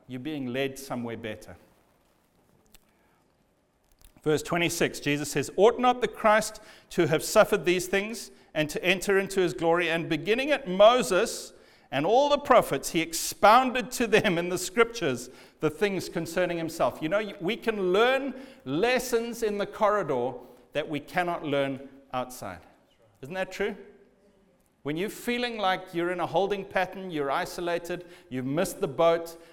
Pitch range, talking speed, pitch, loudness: 150-210 Hz, 150 wpm, 180 Hz, -26 LUFS